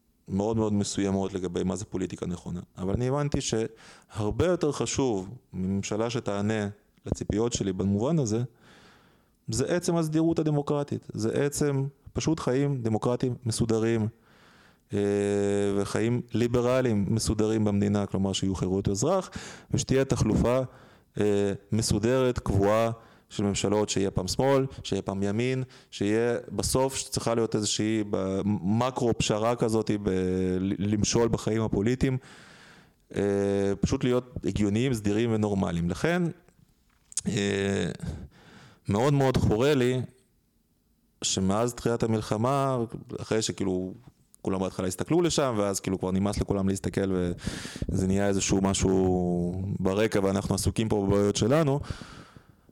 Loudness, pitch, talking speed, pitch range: -27 LUFS, 110 Hz, 110 wpm, 100-125 Hz